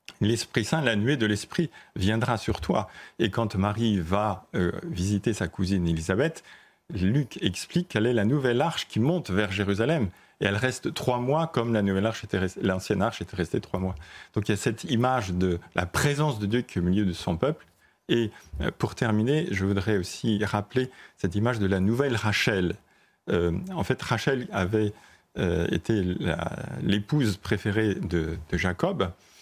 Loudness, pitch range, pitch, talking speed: -27 LUFS, 95-115 Hz, 105 Hz, 185 wpm